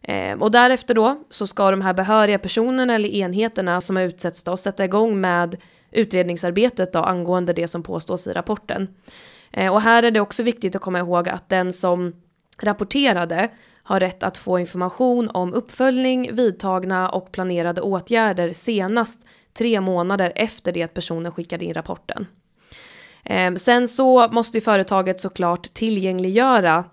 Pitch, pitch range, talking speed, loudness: 195 Hz, 180-230 Hz, 155 wpm, -20 LUFS